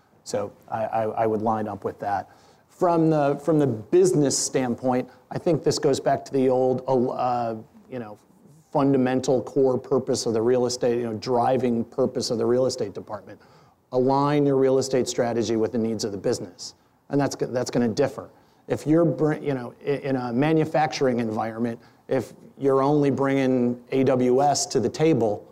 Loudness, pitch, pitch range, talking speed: -23 LUFS, 130 Hz, 120-140 Hz, 175 wpm